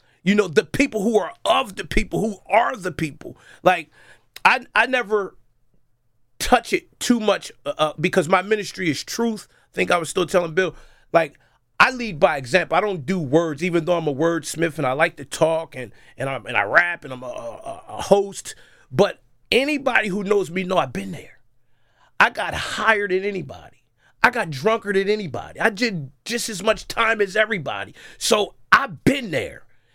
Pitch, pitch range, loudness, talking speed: 185 Hz, 160-215 Hz, -21 LUFS, 190 wpm